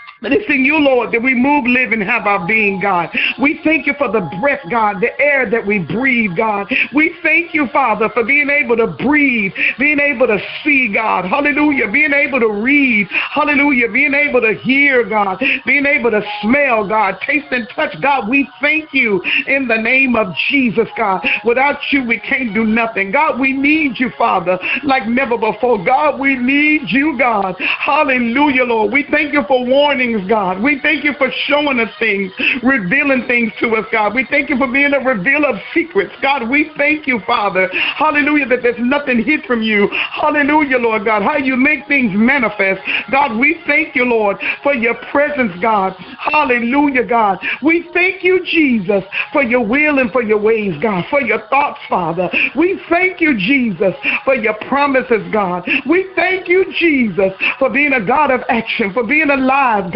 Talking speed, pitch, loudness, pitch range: 185 wpm, 260 Hz, -13 LUFS, 225-290 Hz